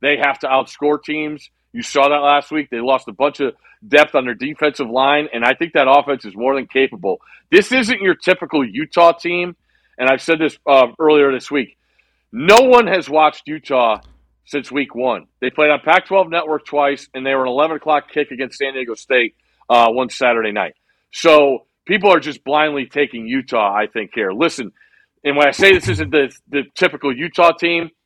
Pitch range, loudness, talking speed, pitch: 135-165 Hz, -16 LUFS, 205 wpm, 145 Hz